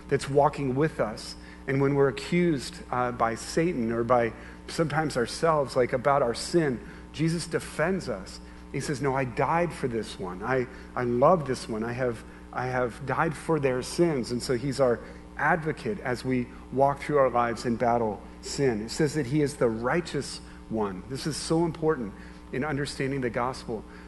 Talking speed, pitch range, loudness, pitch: 180 wpm, 115-150 Hz, -28 LUFS, 130 Hz